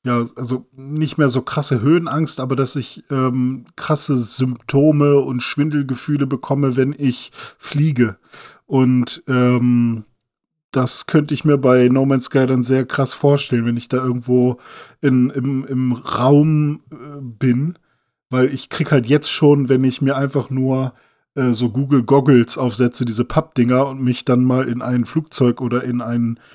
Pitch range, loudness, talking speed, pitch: 125-140 Hz, -17 LUFS, 160 wpm, 130 Hz